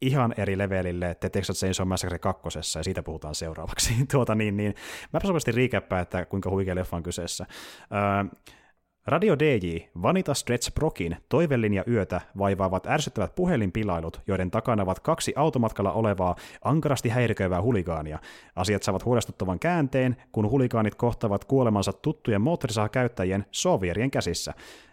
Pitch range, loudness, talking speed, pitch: 90-125 Hz, -27 LUFS, 140 wpm, 100 Hz